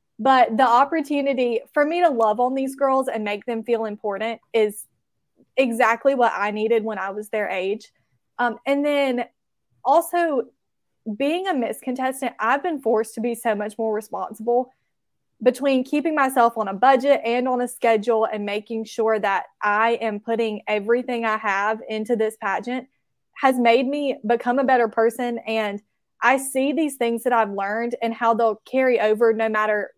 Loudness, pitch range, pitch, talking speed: -22 LUFS, 220-260 Hz, 235 Hz, 175 wpm